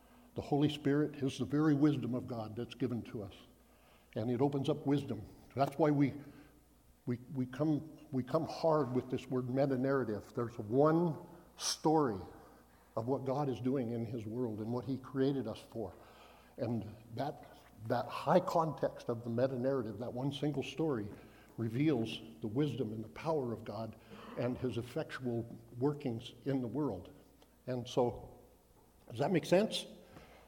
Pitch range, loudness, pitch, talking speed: 115-145 Hz, -36 LUFS, 130 Hz, 165 wpm